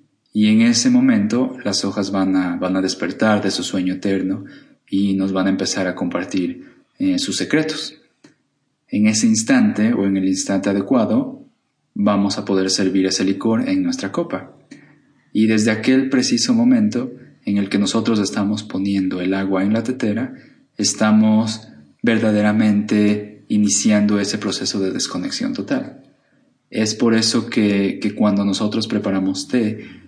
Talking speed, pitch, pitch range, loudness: 150 wpm, 105 Hz, 100-155 Hz, -18 LUFS